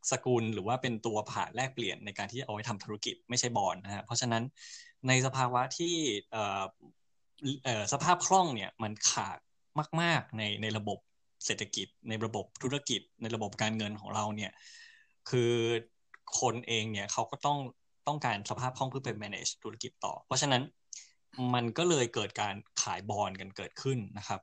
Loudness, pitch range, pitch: -33 LUFS, 105-135 Hz, 120 Hz